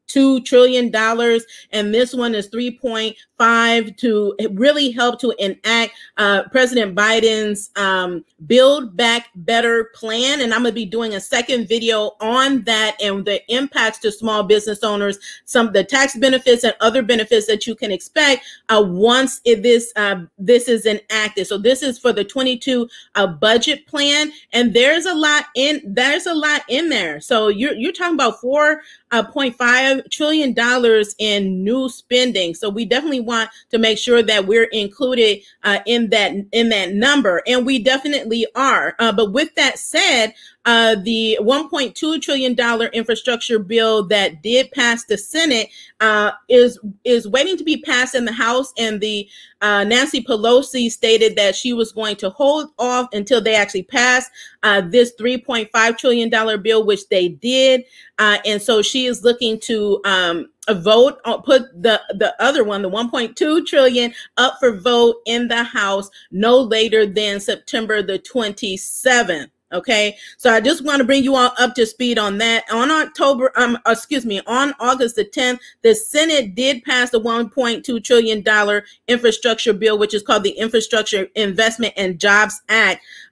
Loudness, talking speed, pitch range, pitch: -16 LUFS, 170 wpm, 215-255 Hz, 230 Hz